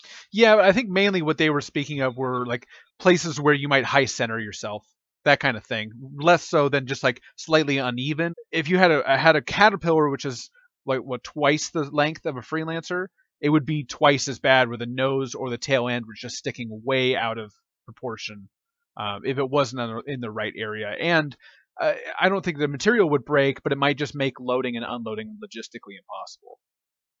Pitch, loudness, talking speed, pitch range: 140 Hz, -23 LUFS, 205 wpm, 120-160 Hz